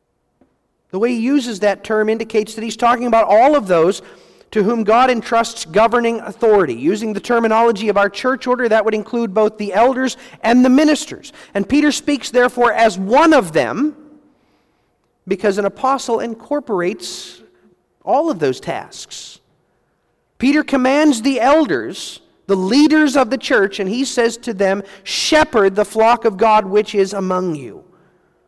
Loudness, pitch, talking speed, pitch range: -15 LUFS, 230 Hz, 160 wpm, 210-265 Hz